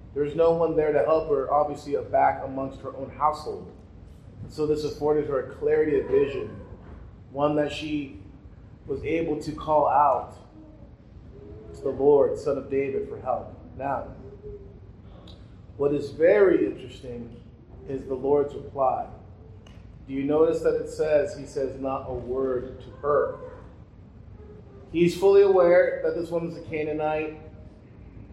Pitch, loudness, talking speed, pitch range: 140 Hz, -25 LUFS, 145 wpm, 105-165 Hz